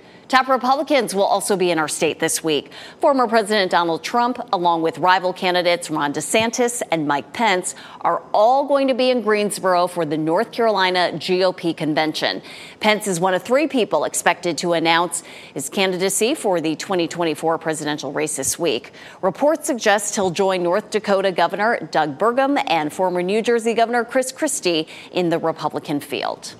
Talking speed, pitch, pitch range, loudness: 165 wpm, 185 Hz, 165-230 Hz, -19 LUFS